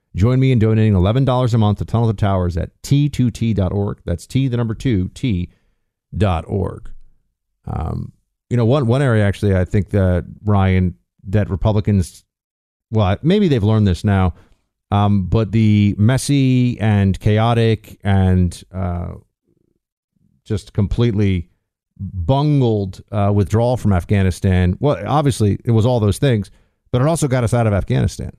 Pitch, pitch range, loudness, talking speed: 105 Hz, 95-120 Hz, -17 LUFS, 150 wpm